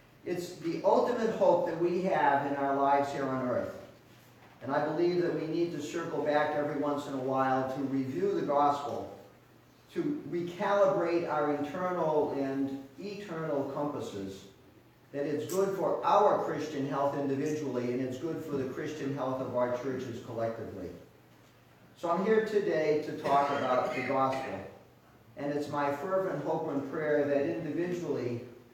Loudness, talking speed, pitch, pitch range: -31 LUFS, 155 wpm, 145 Hz, 135-165 Hz